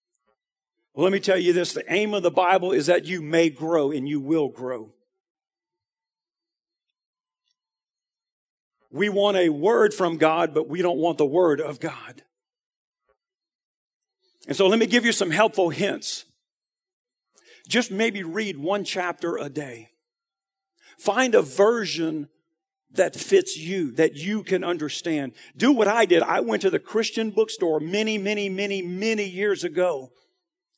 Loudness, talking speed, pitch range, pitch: -22 LUFS, 150 wpm, 165-230 Hz, 195 Hz